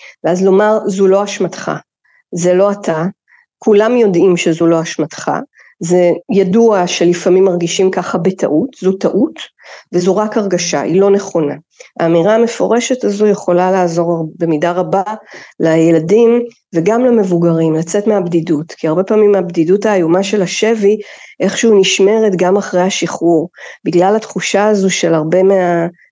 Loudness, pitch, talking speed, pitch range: -12 LUFS, 190 Hz, 130 wpm, 175-210 Hz